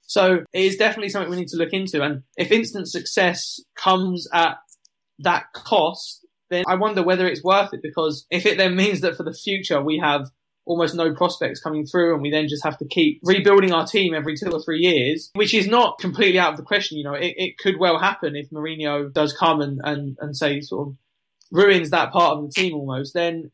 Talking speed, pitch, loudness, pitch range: 225 wpm, 170 Hz, -20 LUFS, 150-190 Hz